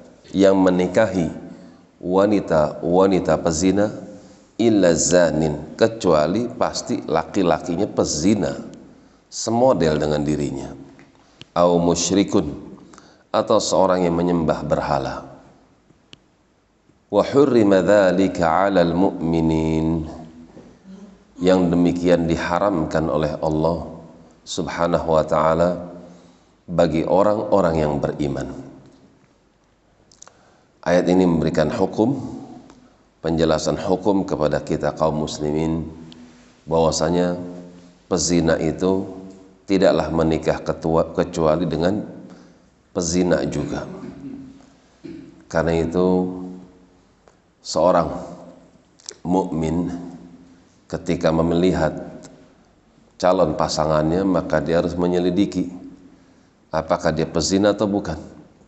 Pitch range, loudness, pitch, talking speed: 80-90 Hz, -20 LUFS, 85 Hz, 70 wpm